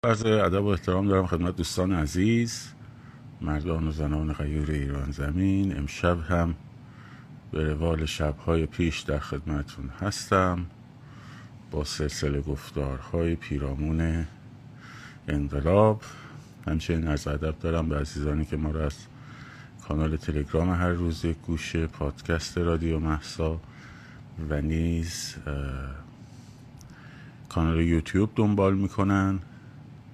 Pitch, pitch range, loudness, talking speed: 85 Hz, 75-110 Hz, -28 LUFS, 105 wpm